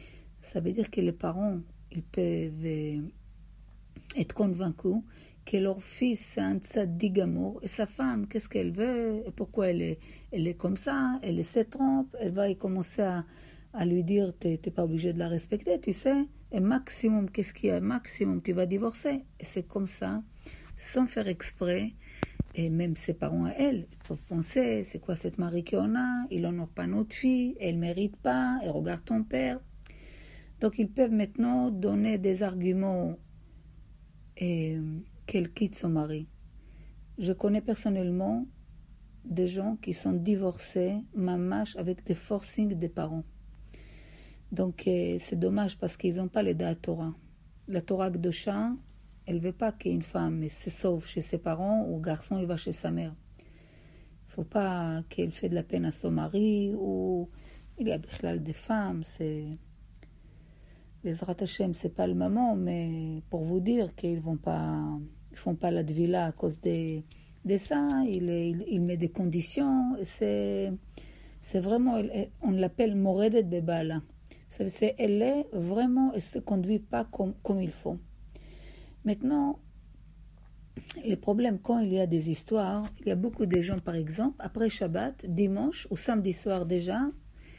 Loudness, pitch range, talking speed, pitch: -31 LUFS, 165-215 Hz, 170 wpm, 185 Hz